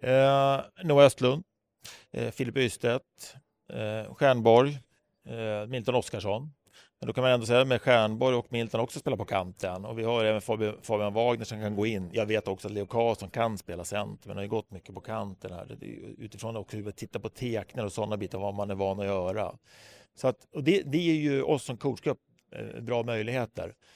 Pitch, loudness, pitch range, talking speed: 115 Hz, -29 LUFS, 105-125 Hz, 210 wpm